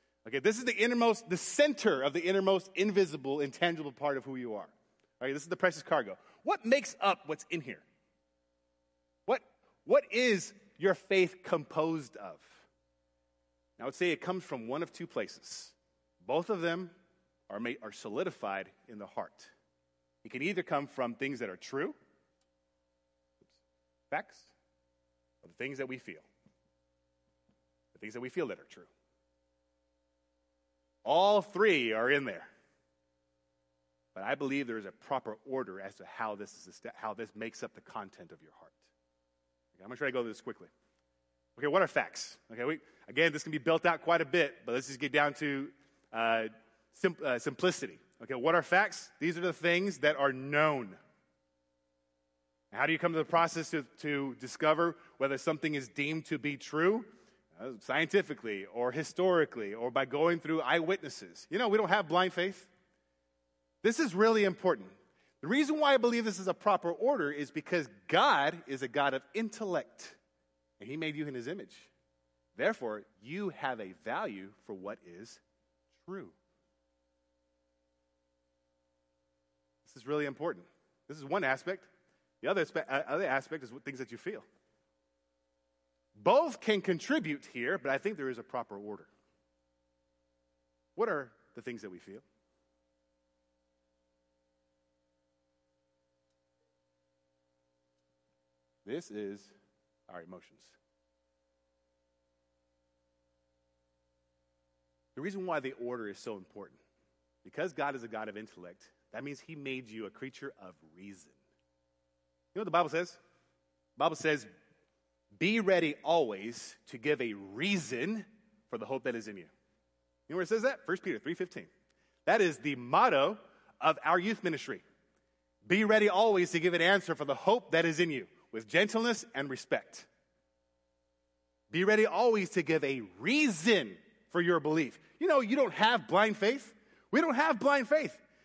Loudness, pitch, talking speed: -32 LUFS, 125 Hz, 160 wpm